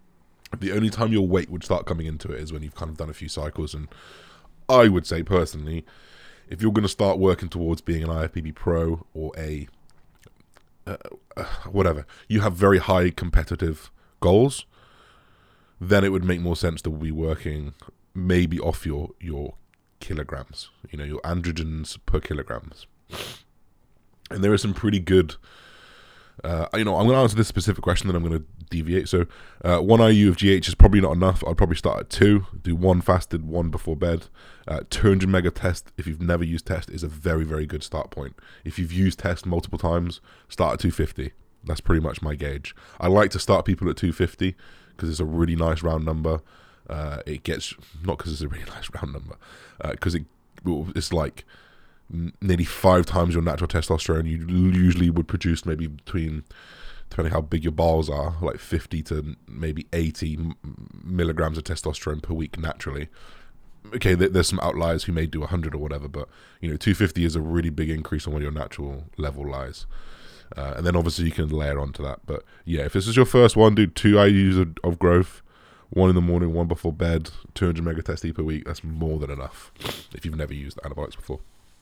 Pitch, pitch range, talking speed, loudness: 85 Hz, 80-95 Hz, 195 wpm, -23 LUFS